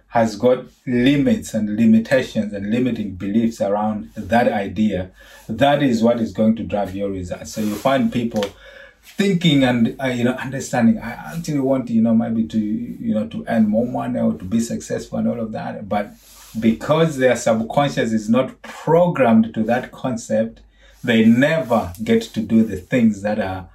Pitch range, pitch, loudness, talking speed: 110-160 Hz, 120 Hz, -19 LUFS, 175 wpm